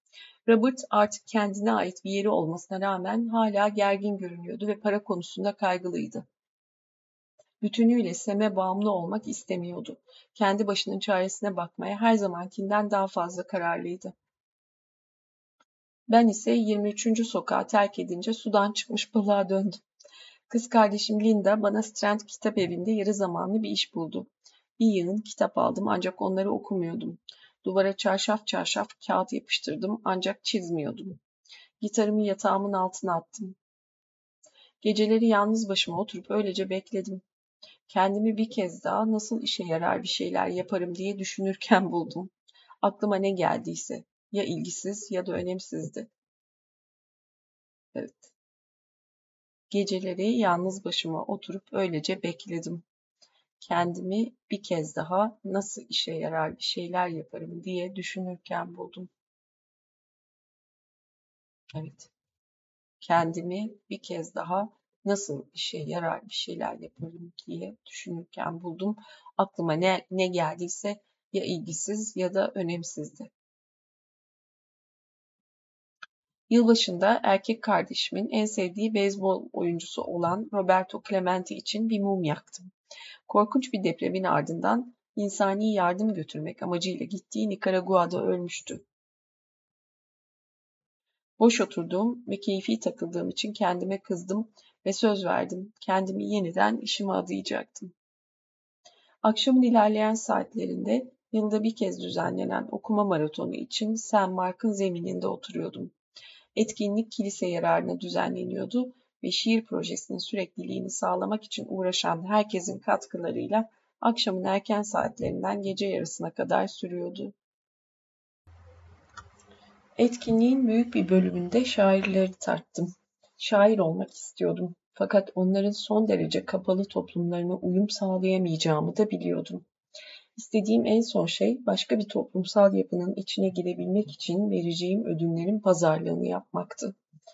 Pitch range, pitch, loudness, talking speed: 180-215 Hz, 195 Hz, -28 LUFS, 110 wpm